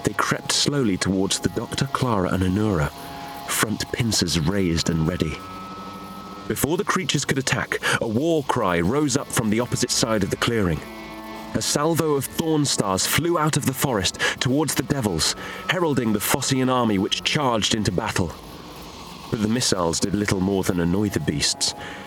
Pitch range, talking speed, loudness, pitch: 95-135 Hz, 170 wpm, -22 LUFS, 110 Hz